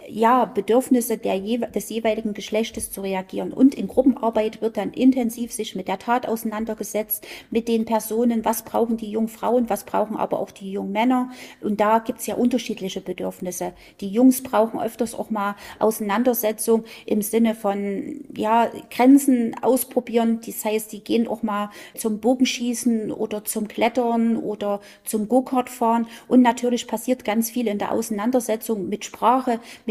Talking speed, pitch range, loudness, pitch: 160 wpm, 215-240 Hz, -22 LUFS, 225 Hz